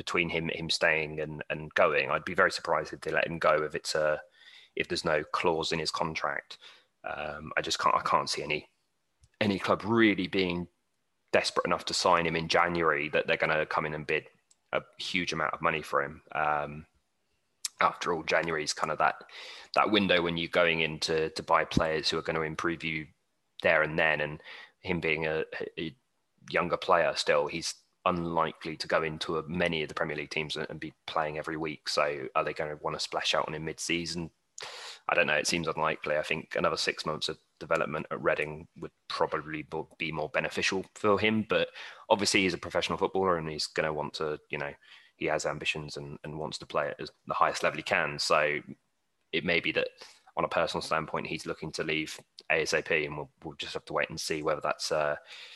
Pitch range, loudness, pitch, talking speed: 75-85 Hz, -30 LUFS, 80 Hz, 215 wpm